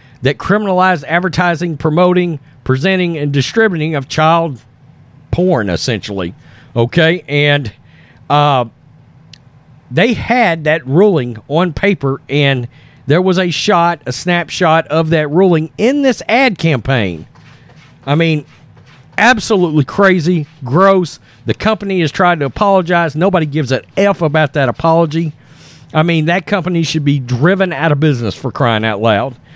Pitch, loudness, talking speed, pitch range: 155 Hz, -13 LUFS, 135 wpm, 140-180 Hz